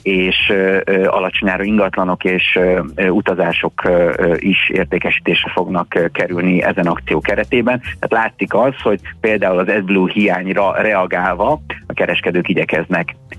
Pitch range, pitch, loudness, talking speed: 90-100 Hz, 95 Hz, -15 LUFS, 110 wpm